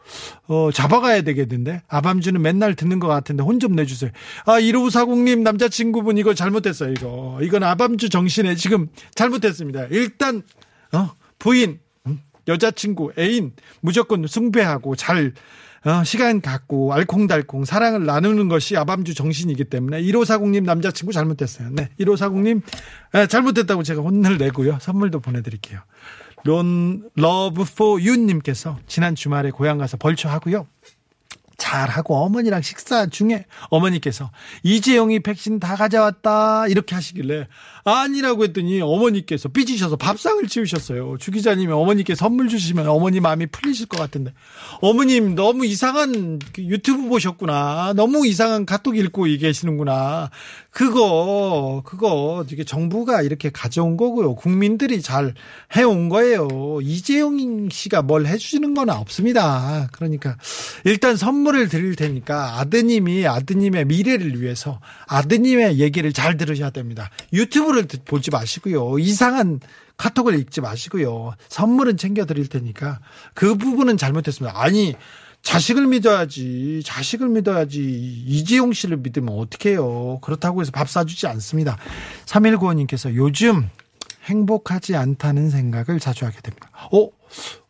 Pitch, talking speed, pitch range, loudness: 175 Hz, 325 characters per minute, 145-215 Hz, -19 LUFS